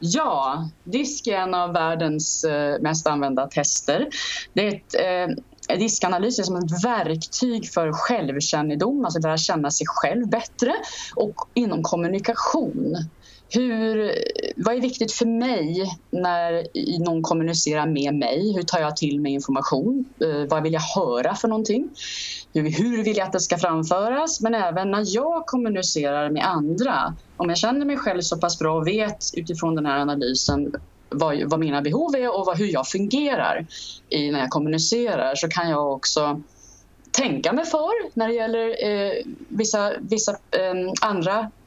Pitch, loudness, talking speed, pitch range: 185 Hz, -23 LUFS, 155 wpm, 155-230 Hz